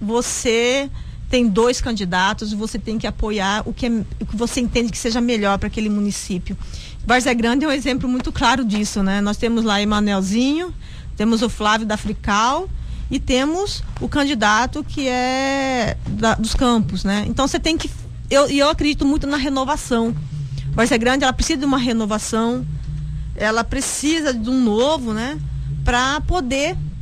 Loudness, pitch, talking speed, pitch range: -19 LUFS, 235 Hz, 165 wpm, 210-265 Hz